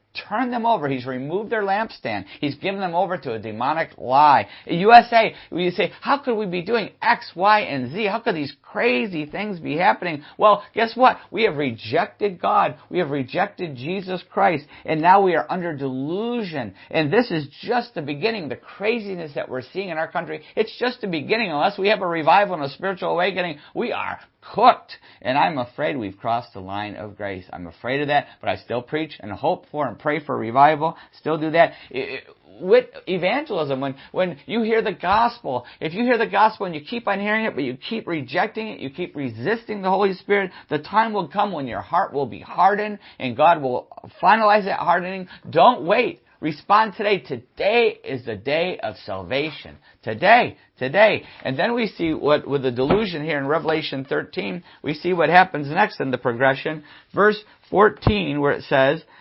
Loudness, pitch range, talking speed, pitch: -21 LUFS, 145-210 Hz, 200 wpm, 175 Hz